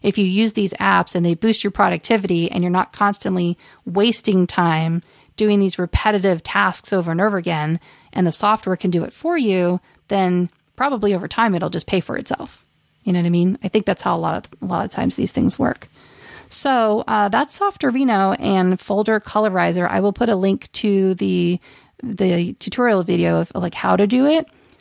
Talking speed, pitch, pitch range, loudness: 200 wpm, 195 Hz, 180-215 Hz, -19 LUFS